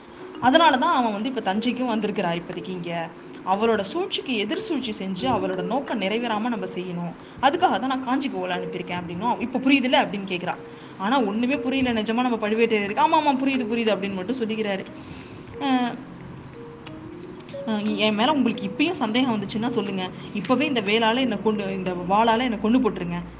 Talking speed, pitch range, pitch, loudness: 155 wpm, 200-255 Hz, 225 Hz, -23 LUFS